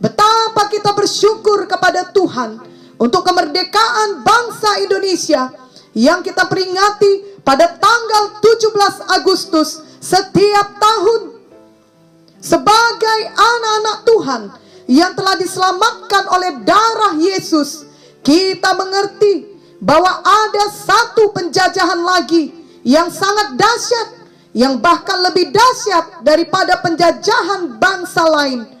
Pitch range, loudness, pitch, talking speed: 335-415 Hz, -13 LUFS, 375 Hz, 95 wpm